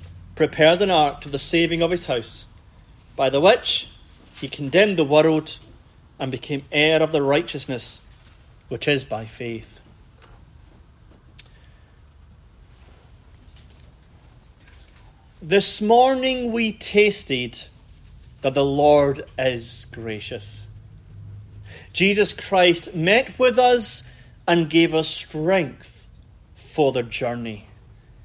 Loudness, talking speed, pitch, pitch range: -20 LUFS, 100 wpm, 130 Hz, 110-165 Hz